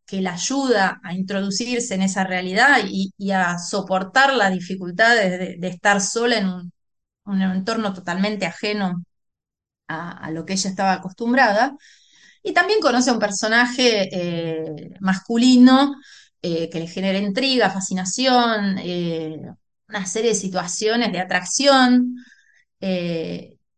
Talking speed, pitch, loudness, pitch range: 135 wpm, 195 Hz, -19 LUFS, 185-235 Hz